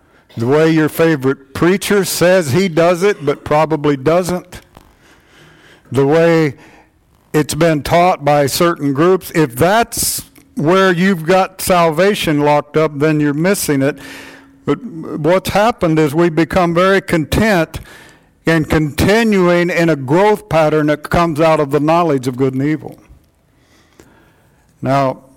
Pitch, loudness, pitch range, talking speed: 160 Hz, -14 LUFS, 145-175 Hz, 135 wpm